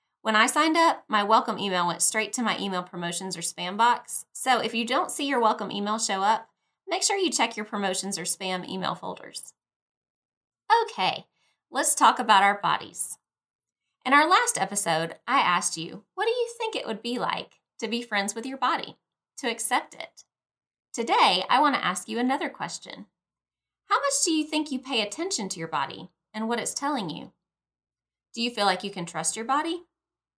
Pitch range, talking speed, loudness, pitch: 190-280 Hz, 195 wpm, -25 LUFS, 220 Hz